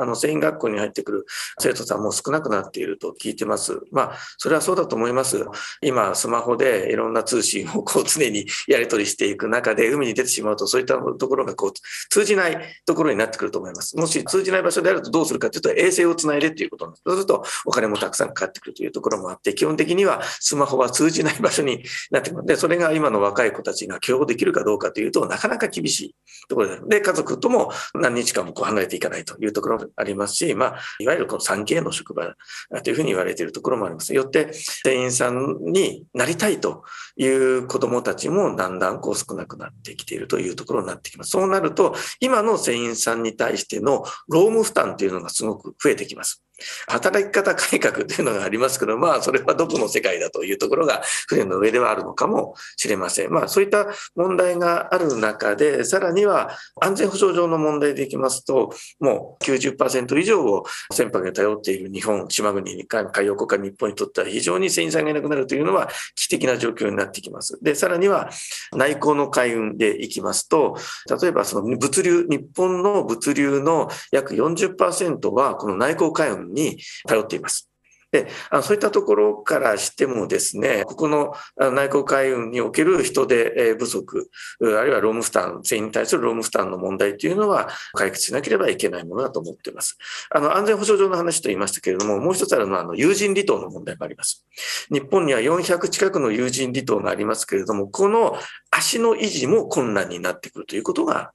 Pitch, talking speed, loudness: 200 Hz, 430 characters per minute, -21 LUFS